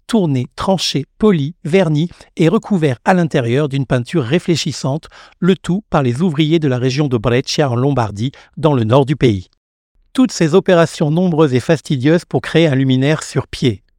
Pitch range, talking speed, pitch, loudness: 130-175 Hz, 170 wpm, 155 Hz, -15 LUFS